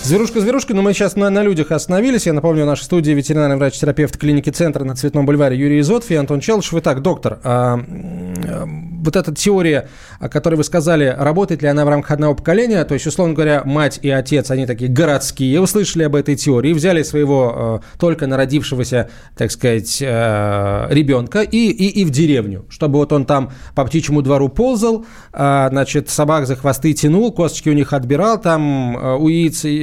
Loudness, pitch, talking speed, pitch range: -15 LUFS, 150 Hz, 185 wpm, 135-170 Hz